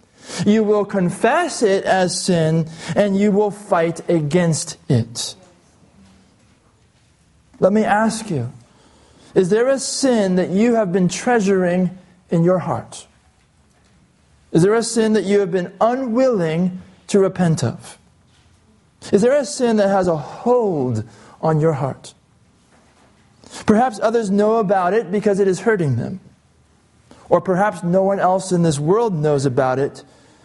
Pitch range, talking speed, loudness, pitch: 160-215 Hz, 140 wpm, -18 LUFS, 185 Hz